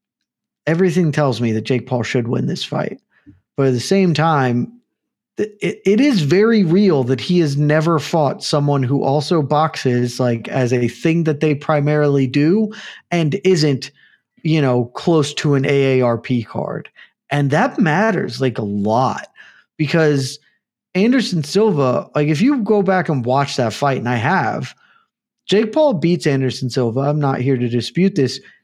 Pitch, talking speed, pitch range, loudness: 150 Hz, 165 wpm, 130-180 Hz, -17 LUFS